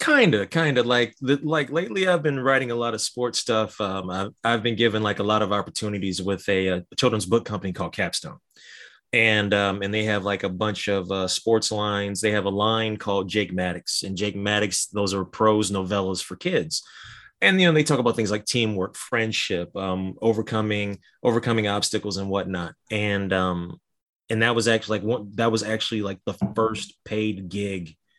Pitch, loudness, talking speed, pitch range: 105 Hz, -24 LUFS, 195 wpm, 100-115 Hz